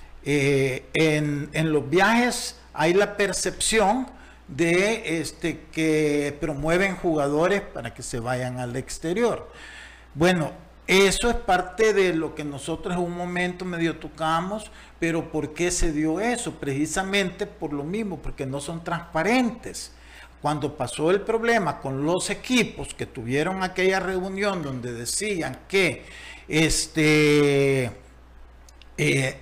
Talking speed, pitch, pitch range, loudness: 125 wpm, 160 Hz, 145-190 Hz, -24 LUFS